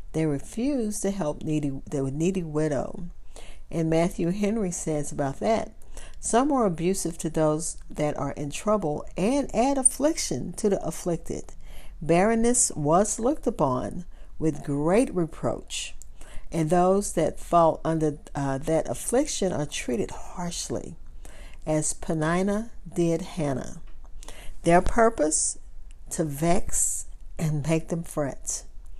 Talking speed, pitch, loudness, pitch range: 120 wpm, 165 Hz, -26 LUFS, 150-195 Hz